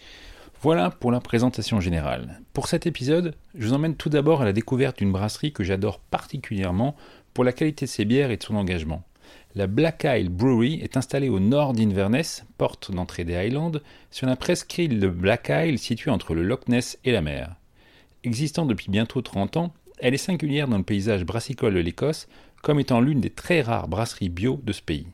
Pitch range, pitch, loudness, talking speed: 100-140 Hz, 120 Hz, -24 LUFS, 200 wpm